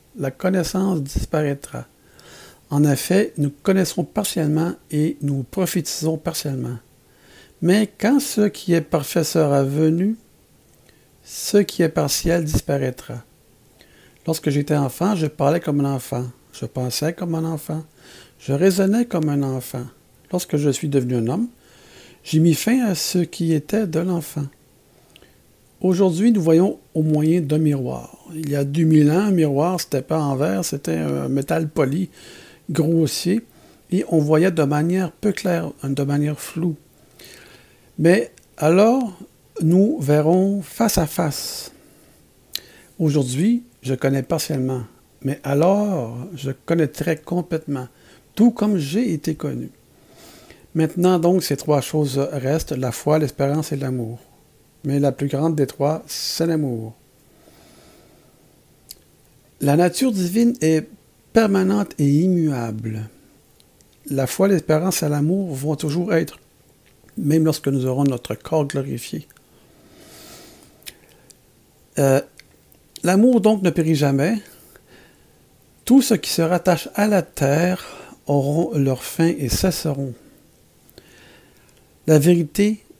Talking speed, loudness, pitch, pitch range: 125 wpm, -20 LUFS, 155 Hz, 140-180 Hz